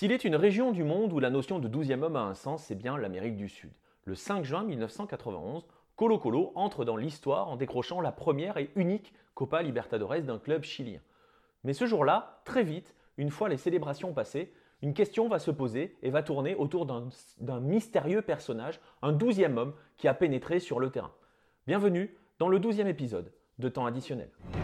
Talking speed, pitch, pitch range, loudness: 195 wpm, 150 Hz, 130-190 Hz, -32 LUFS